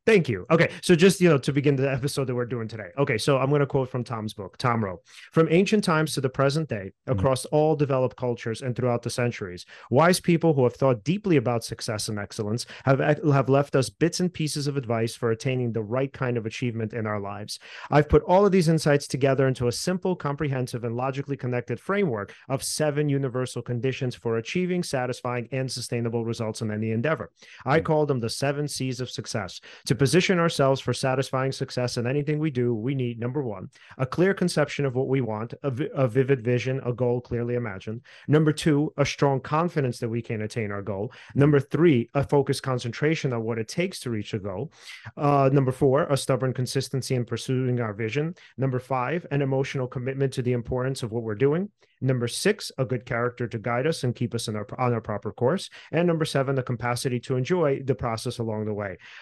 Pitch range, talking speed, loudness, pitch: 120-145 Hz, 215 wpm, -25 LUFS, 130 Hz